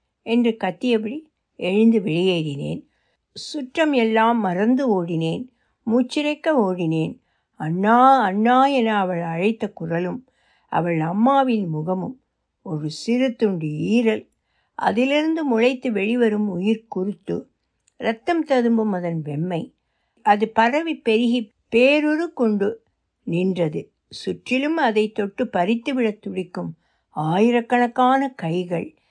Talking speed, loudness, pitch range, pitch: 95 wpm, -21 LUFS, 185-250 Hz, 225 Hz